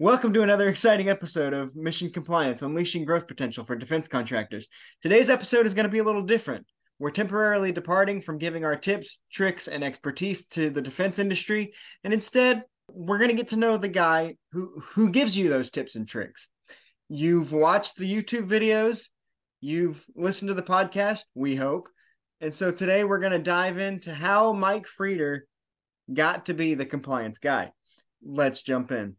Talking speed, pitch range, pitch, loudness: 180 wpm, 150-205 Hz, 185 Hz, -25 LUFS